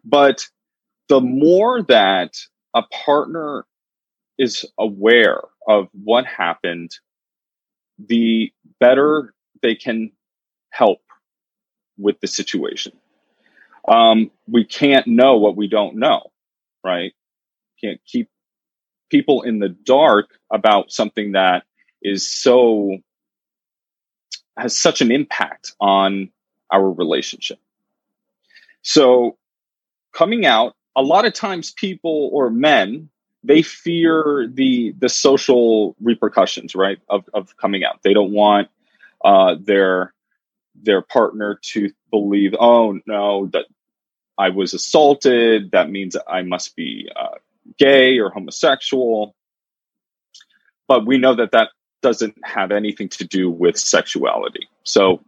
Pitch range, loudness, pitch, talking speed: 100-145 Hz, -16 LUFS, 115 Hz, 115 wpm